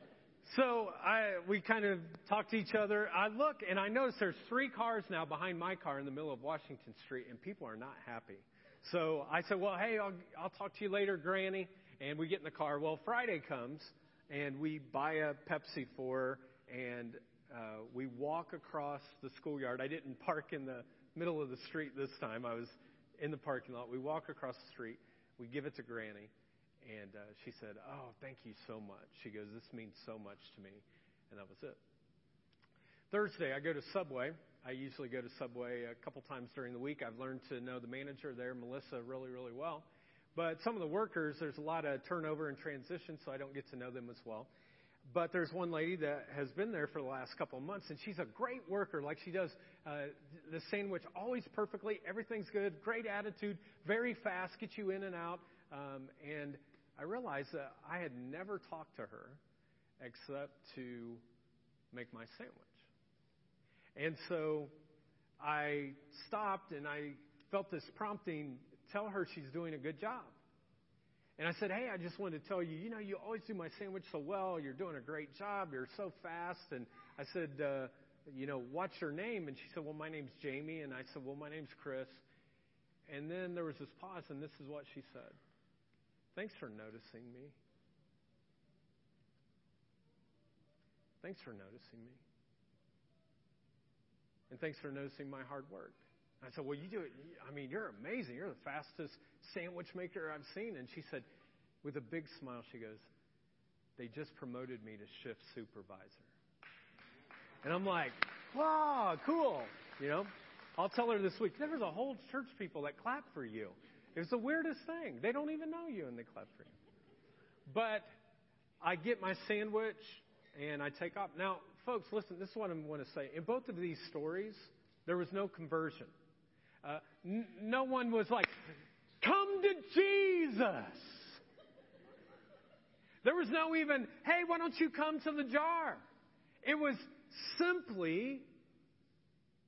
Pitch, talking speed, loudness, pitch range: 155 Hz, 185 wpm, -41 LUFS, 135-200 Hz